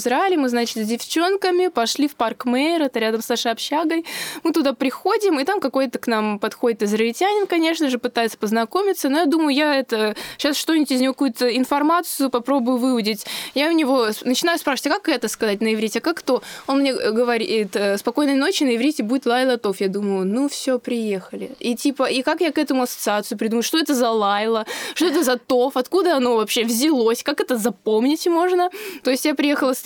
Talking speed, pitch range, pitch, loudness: 200 wpm, 230-305 Hz, 260 Hz, -20 LUFS